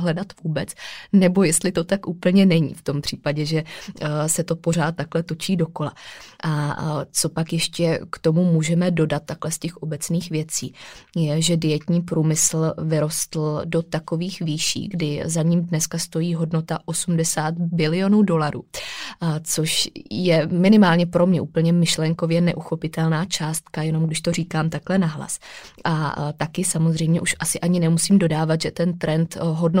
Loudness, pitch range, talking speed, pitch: -21 LUFS, 155-175 Hz, 150 wpm, 165 Hz